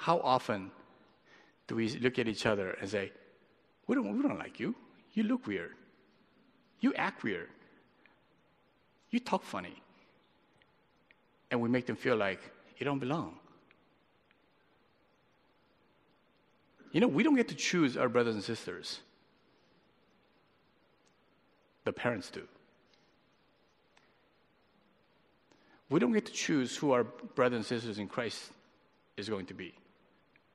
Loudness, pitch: -34 LUFS, 125 Hz